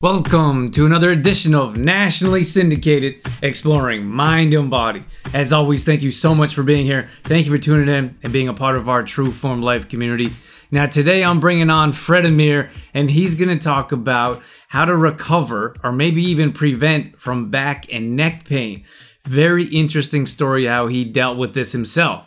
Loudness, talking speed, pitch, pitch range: -16 LUFS, 185 wpm, 145 Hz, 130-160 Hz